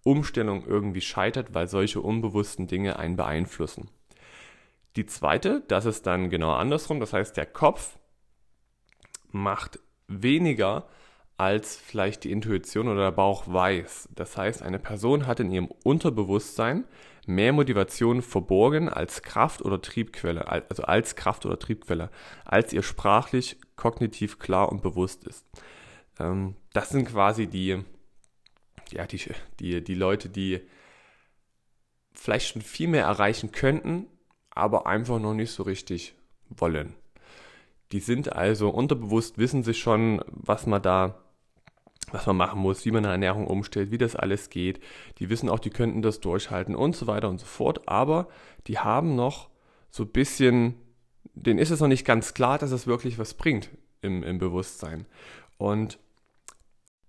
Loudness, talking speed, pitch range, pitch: -27 LUFS, 150 wpm, 95-120 Hz, 105 Hz